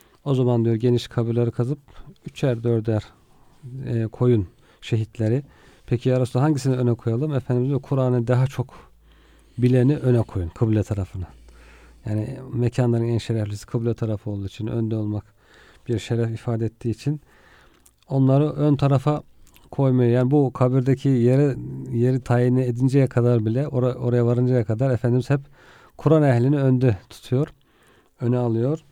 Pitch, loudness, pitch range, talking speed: 125 Hz, -22 LUFS, 115-135 Hz, 135 wpm